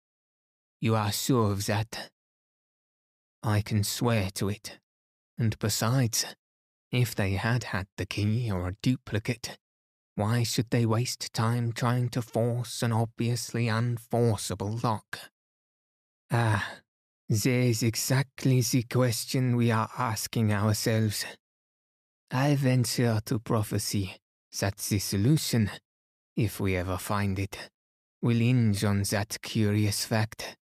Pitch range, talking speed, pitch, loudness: 100-120 Hz, 120 wpm, 110 Hz, -28 LUFS